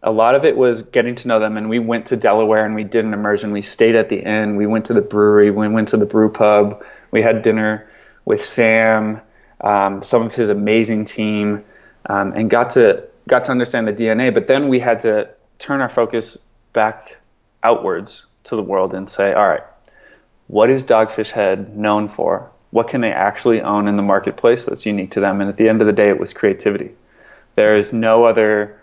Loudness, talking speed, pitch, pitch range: -16 LUFS, 215 wpm, 110 Hz, 105-115 Hz